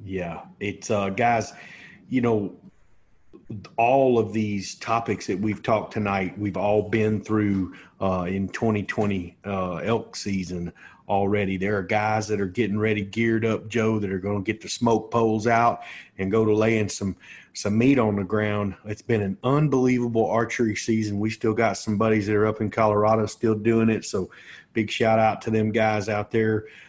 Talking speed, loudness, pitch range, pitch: 180 wpm, -24 LUFS, 100-115 Hz, 110 Hz